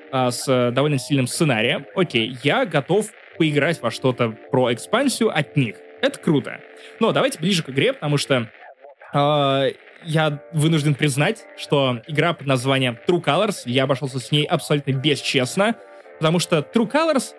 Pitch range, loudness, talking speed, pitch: 130-160 Hz, -20 LUFS, 150 wpm, 145 Hz